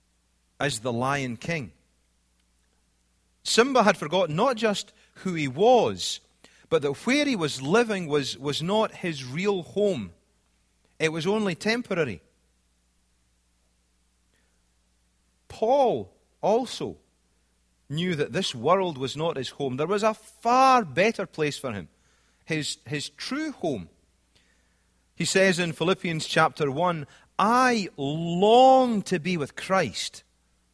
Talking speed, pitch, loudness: 120 wpm, 150 Hz, -25 LUFS